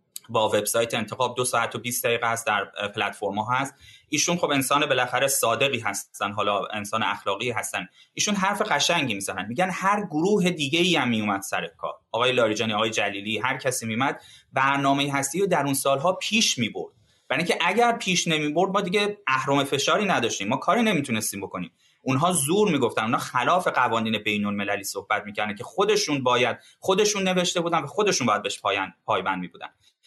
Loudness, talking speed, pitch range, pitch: -24 LUFS, 175 wpm, 115-185 Hz, 140 Hz